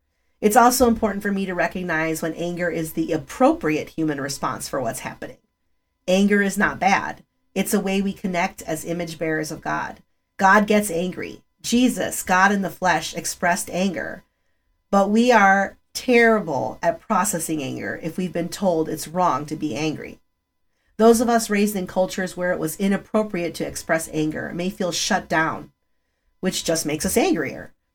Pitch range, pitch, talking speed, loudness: 165-205 Hz, 180 Hz, 170 wpm, -21 LUFS